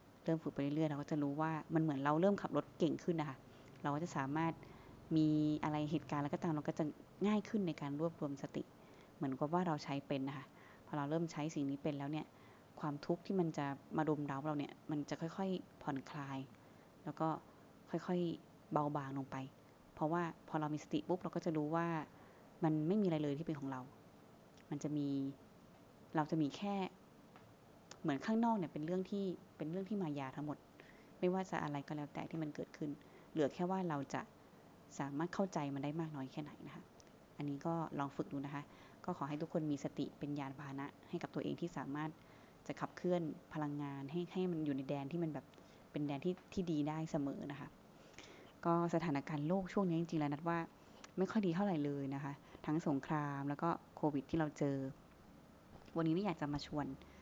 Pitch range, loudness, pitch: 145-170 Hz, -41 LUFS, 155 Hz